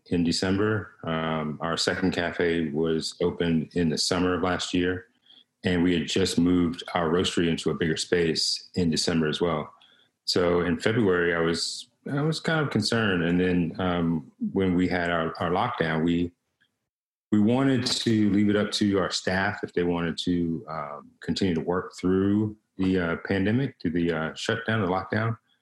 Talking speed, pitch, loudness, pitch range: 180 wpm, 90 Hz, -26 LUFS, 85-105 Hz